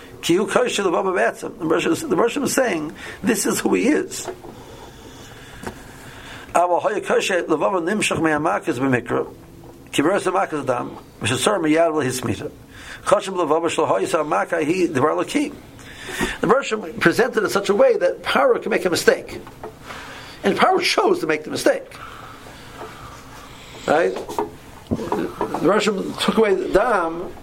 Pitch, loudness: 220 Hz, -20 LUFS